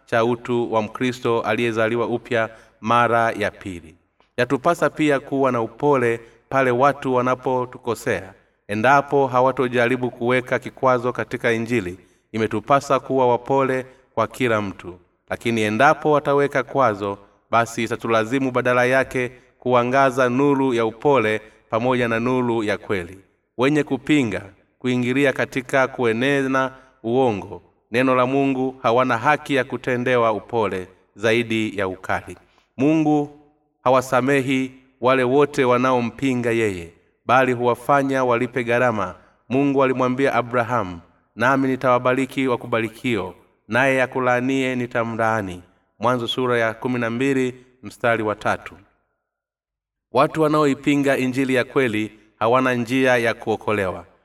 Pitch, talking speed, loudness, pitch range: 125 Hz, 105 wpm, -20 LUFS, 115-130 Hz